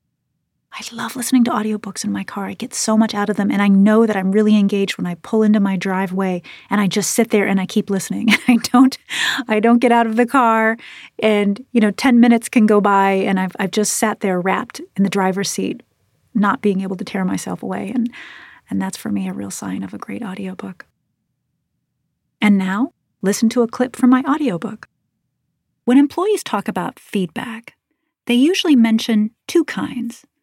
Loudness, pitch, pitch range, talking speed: -17 LUFS, 215 Hz, 195-245 Hz, 205 wpm